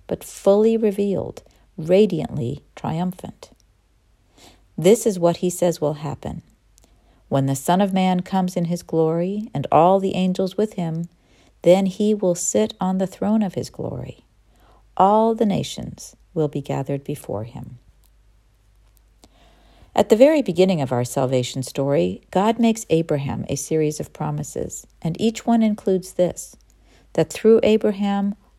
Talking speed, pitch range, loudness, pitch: 145 wpm, 135-200 Hz, -20 LUFS, 175 Hz